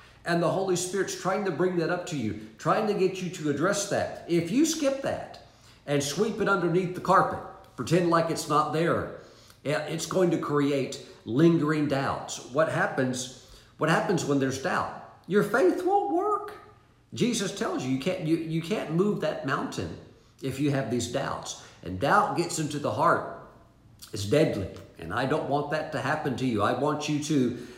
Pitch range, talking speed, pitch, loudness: 135-185 Hz, 190 wpm, 155 Hz, -27 LUFS